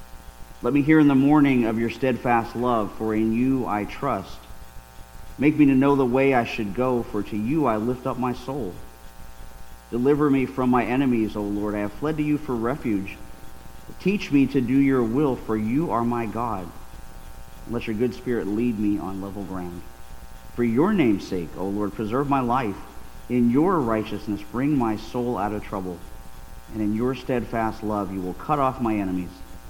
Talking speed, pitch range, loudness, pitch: 190 wpm, 90-125 Hz, -23 LUFS, 110 Hz